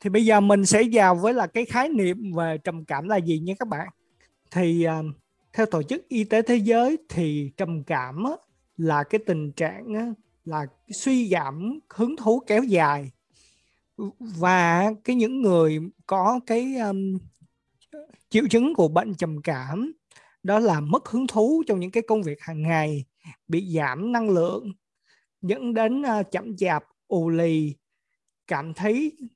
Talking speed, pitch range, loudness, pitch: 160 wpm, 165-225 Hz, -24 LUFS, 195 Hz